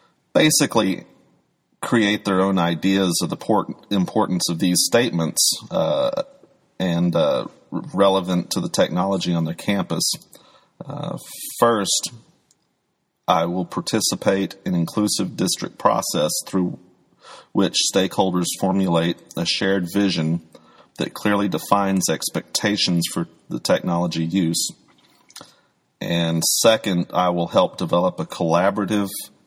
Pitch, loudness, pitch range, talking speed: 95 Hz, -21 LUFS, 85-105 Hz, 110 wpm